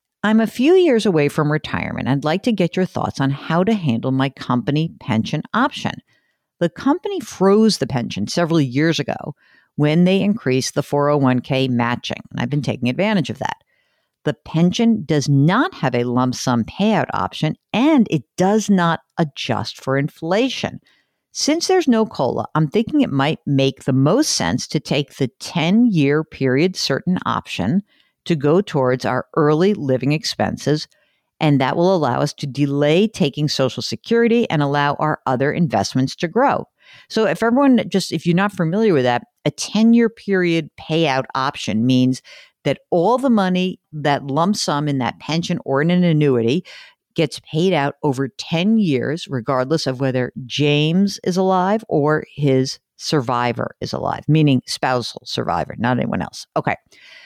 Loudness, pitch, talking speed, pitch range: -18 LUFS, 155 Hz, 165 wpm, 135-190 Hz